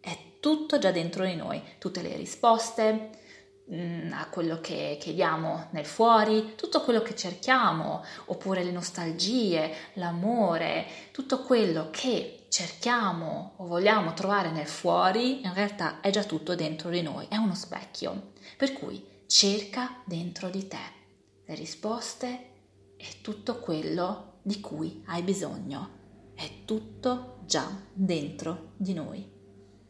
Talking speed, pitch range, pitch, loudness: 130 wpm, 165-220 Hz, 185 Hz, -29 LUFS